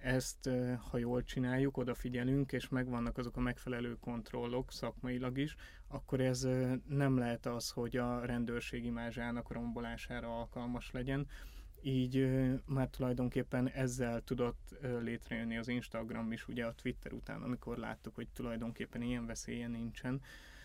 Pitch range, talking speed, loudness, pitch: 120-130 Hz, 130 wpm, -39 LUFS, 125 Hz